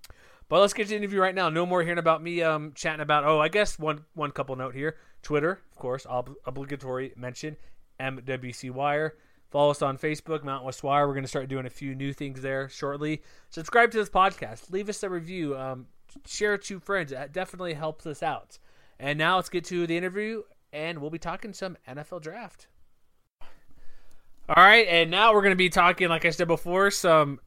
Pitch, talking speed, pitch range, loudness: 155 Hz, 210 wpm, 140-185 Hz, -25 LUFS